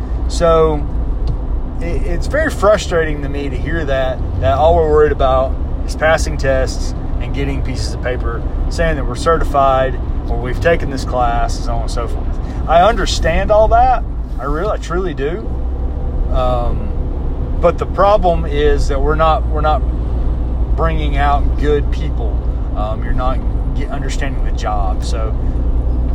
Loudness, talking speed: -17 LUFS, 160 wpm